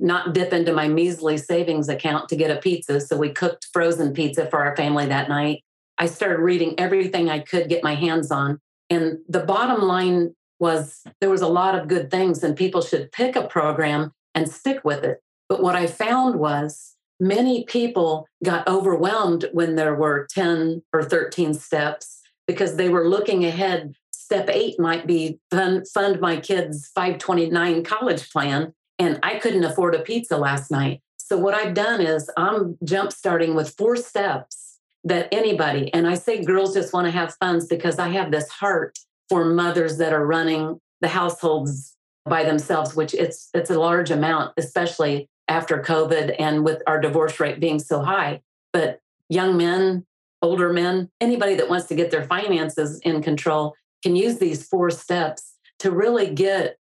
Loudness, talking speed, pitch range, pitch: -22 LUFS, 175 wpm, 155-185 Hz, 170 Hz